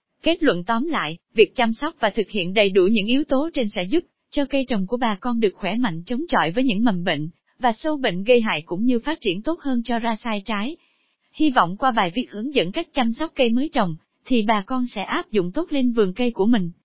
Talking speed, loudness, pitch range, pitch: 260 wpm, -22 LUFS, 210-275 Hz, 240 Hz